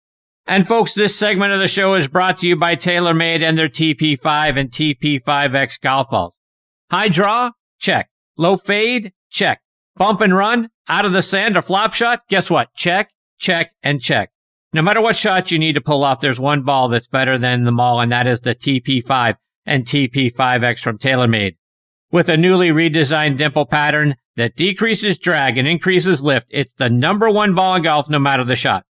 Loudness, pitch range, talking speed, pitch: -15 LUFS, 135-190 Hz, 190 wpm, 155 Hz